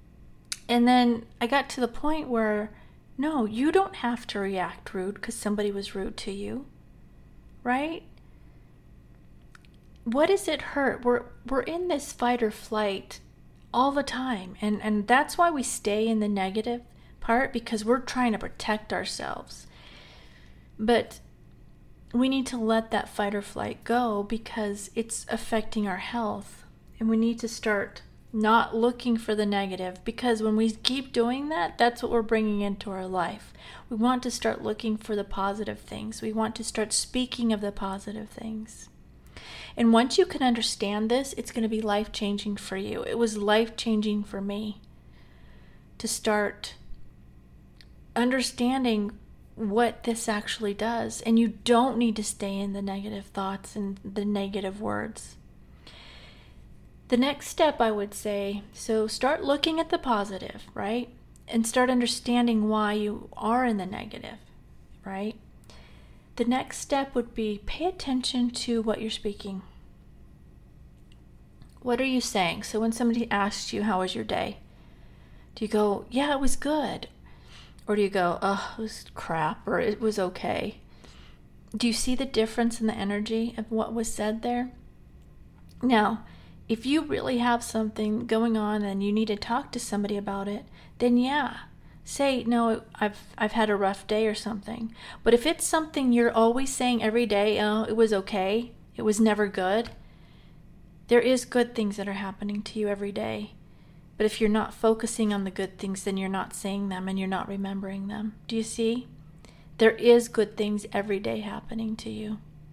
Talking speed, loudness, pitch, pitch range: 170 wpm, -27 LUFS, 220 Hz, 200-235 Hz